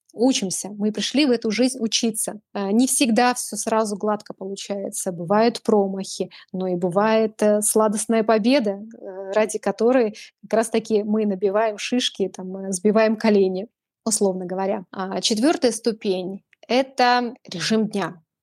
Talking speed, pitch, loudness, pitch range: 125 wpm, 215 Hz, -21 LUFS, 195-230 Hz